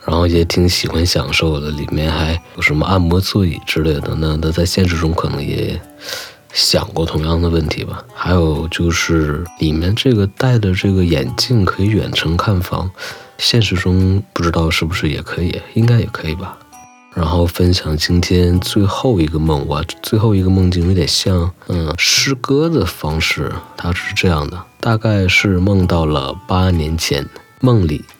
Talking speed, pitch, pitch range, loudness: 255 characters per minute, 90 Hz, 80-100 Hz, -15 LUFS